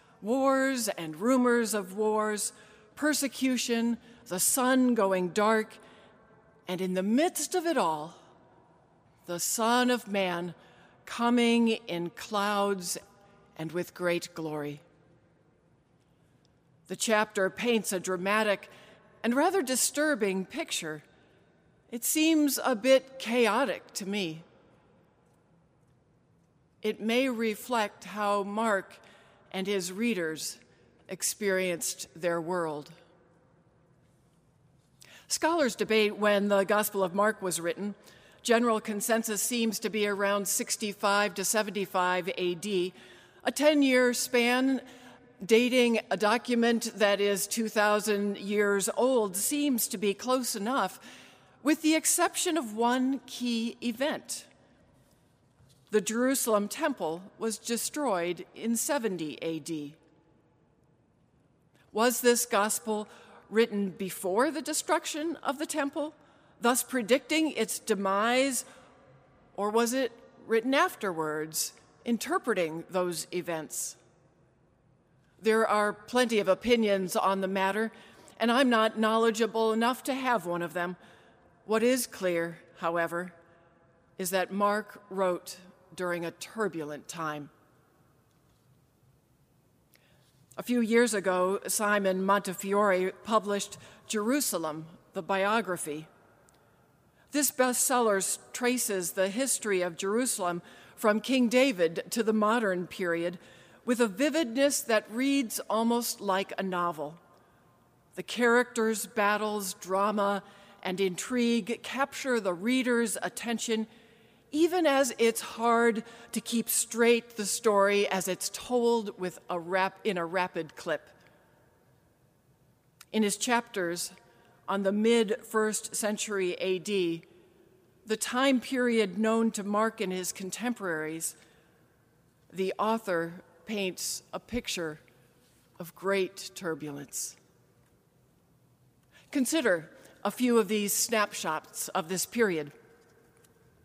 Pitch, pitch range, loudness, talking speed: 205 Hz, 175-235 Hz, -29 LUFS, 105 wpm